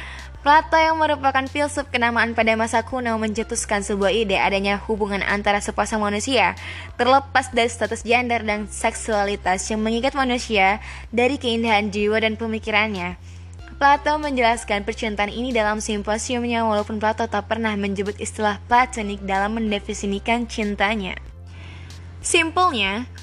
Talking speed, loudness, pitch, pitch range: 120 wpm, -21 LUFS, 220 Hz, 205-240 Hz